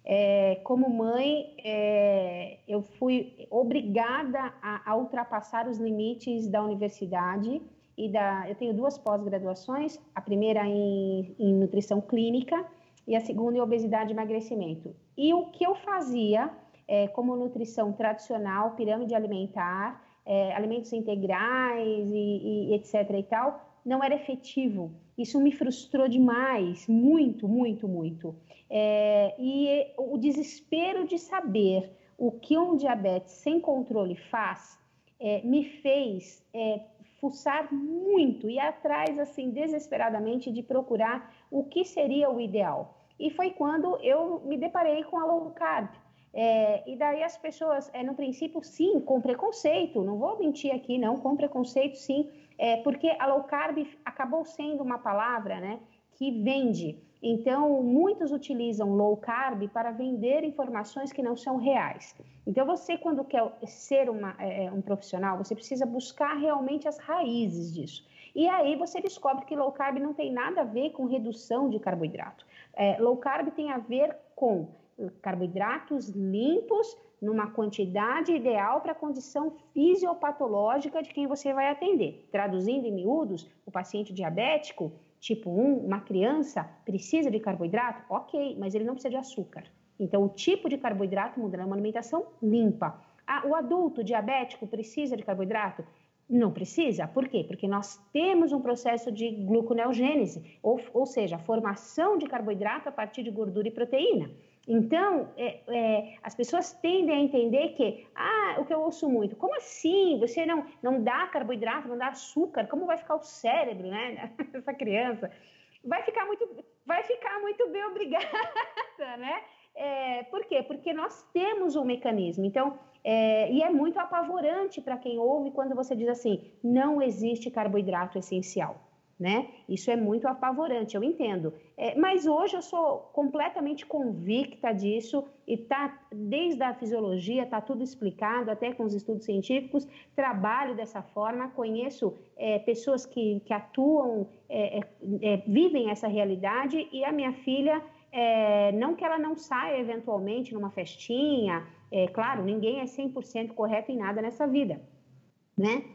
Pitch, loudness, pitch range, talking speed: 245 Hz, -29 LUFS, 210-290 Hz, 150 wpm